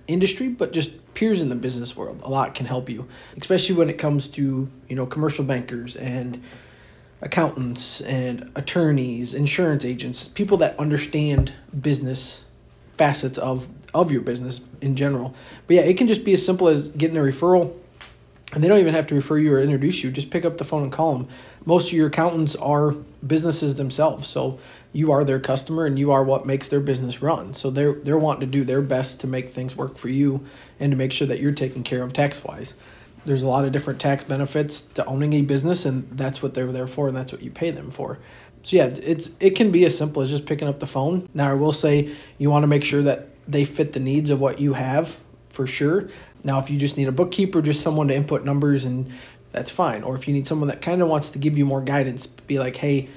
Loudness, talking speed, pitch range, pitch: -22 LUFS, 230 wpm, 130-155 Hz, 140 Hz